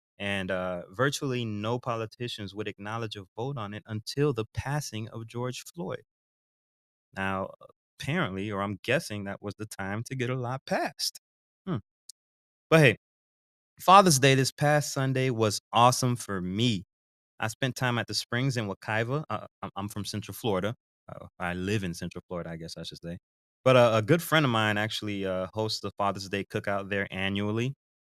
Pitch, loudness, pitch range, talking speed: 105 Hz, -28 LUFS, 95-120 Hz, 180 wpm